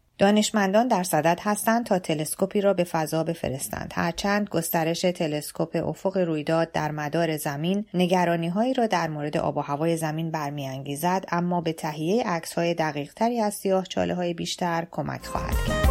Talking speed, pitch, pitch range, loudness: 160 wpm, 170 Hz, 155-195 Hz, -25 LUFS